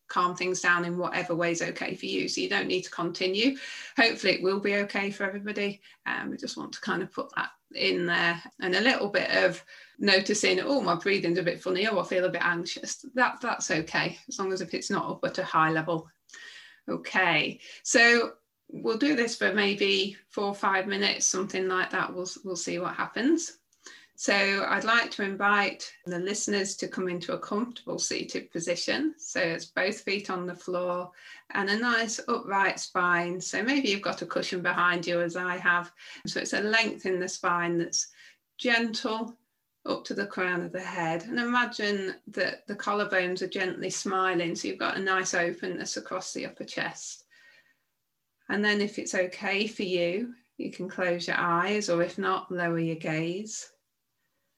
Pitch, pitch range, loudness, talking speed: 190 Hz, 175-215 Hz, -28 LUFS, 190 wpm